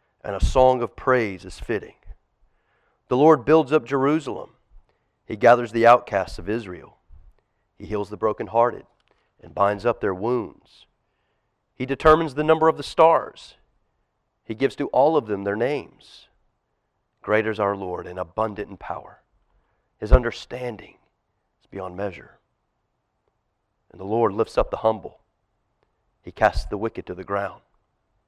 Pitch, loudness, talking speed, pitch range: 110 Hz, -22 LUFS, 145 wpm, 100-120 Hz